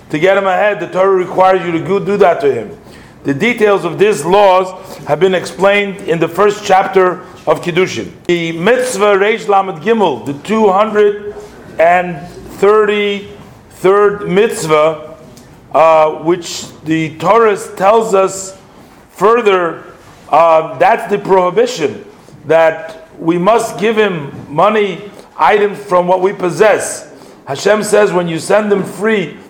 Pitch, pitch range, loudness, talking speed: 190 Hz, 170-205 Hz, -12 LUFS, 130 wpm